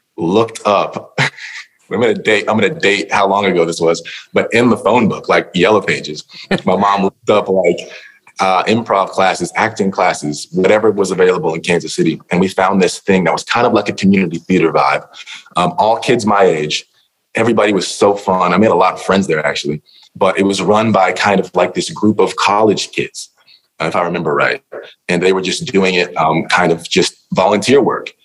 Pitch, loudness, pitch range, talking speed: 95 Hz, -14 LUFS, 85-100 Hz, 205 wpm